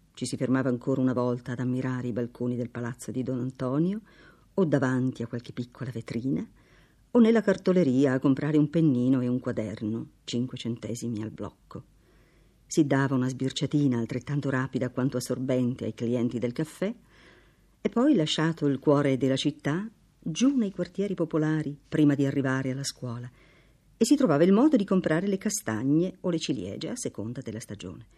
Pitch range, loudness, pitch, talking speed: 125-160 Hz, -27 LUFS, 135 Hz, 170 wpm